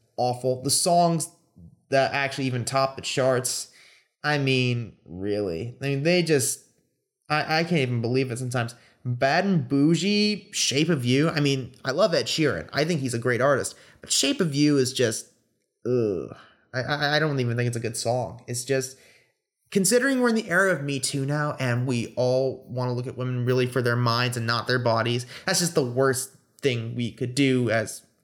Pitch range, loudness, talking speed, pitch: 125-150 Hz, -24 LUFS, 200 wpm, 130 Hz